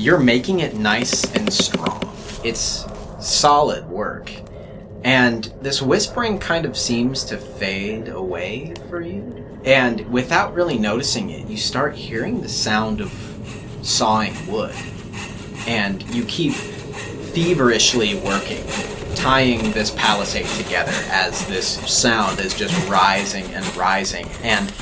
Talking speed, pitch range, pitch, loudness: 125 wpm, 105-130 Hz, 115 Hz, -19 LUFS